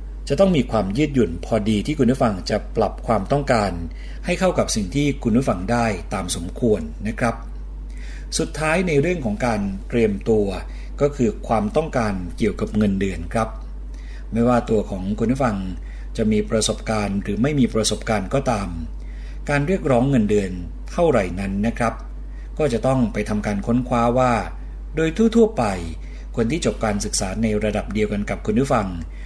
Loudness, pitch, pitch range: -21 LUFS, 105 Hz, 90-120 Hz